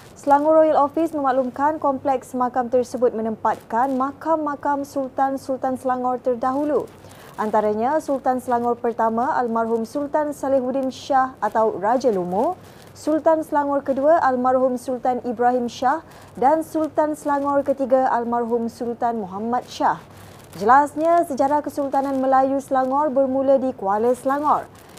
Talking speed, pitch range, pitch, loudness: 115 wpm, 245-285 Hz, 265 Hz, -21 LUFS